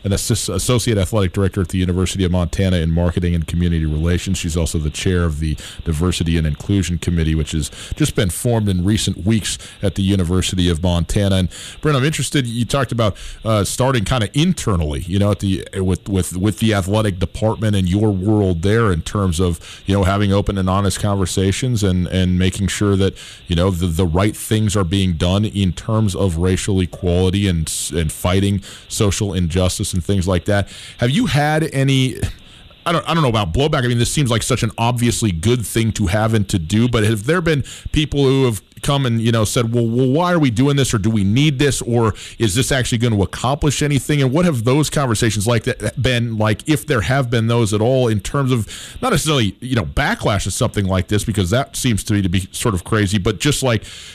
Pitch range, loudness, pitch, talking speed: 95-120 Hz, -18 LUFS, 105 Hz, 220 wpm